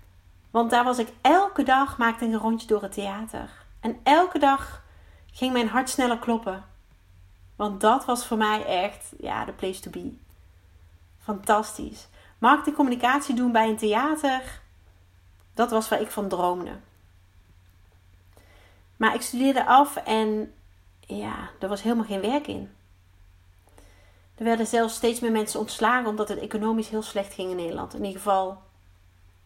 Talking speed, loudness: 155 wpm, -25 LUFS